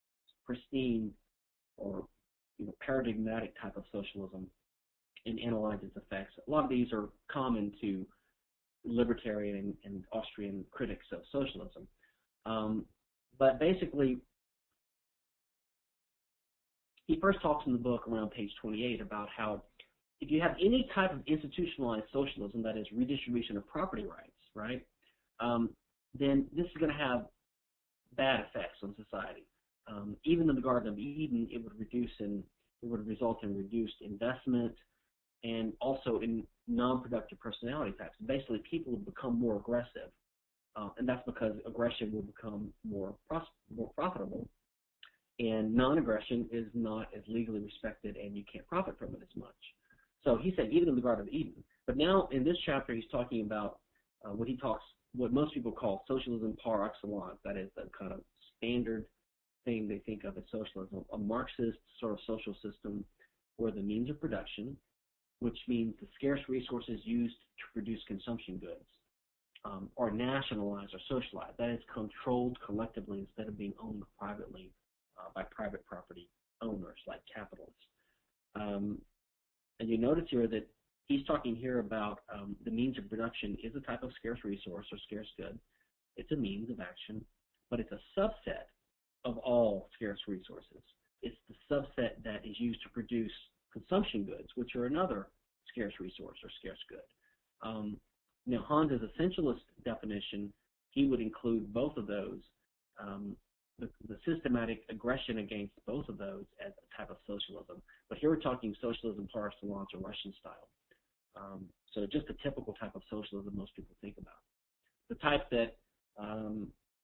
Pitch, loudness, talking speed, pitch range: 115 Hz, -37 LUFS, 155 wpm, 105-125 Hz